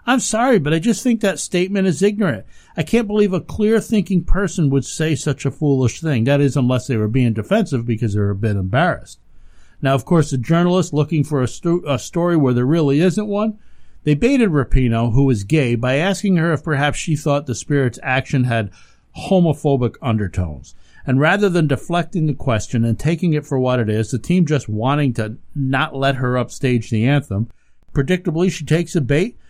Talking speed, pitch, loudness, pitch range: 200 wpm, 145 Hz, -18 LUFS, 125-175 Hz